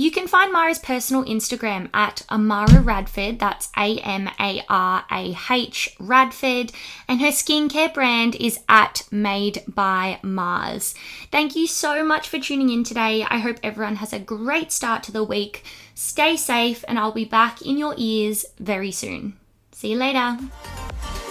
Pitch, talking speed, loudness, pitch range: 230 Hz, 150 wpm, -20 LUFS, 205-265 Hz